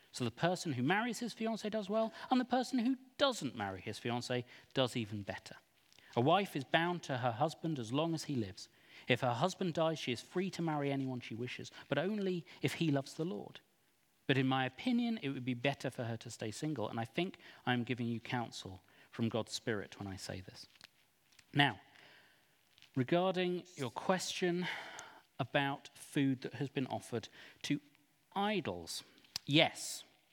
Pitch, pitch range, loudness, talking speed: 140 Hz, 120-180 Hz, -37 LUFS, 180 wpm